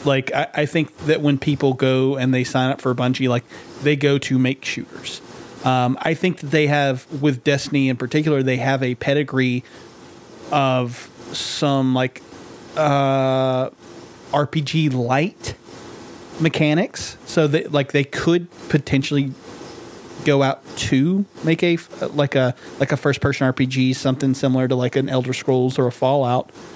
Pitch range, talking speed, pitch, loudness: 130-150 Hz, 155 wpm, 135 Hz, -20 LUFS